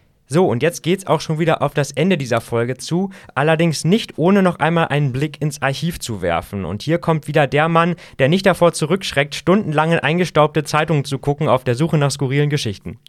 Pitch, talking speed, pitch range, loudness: 155 Hz, 210 wpm, 135-165 Hz, -18 LUFS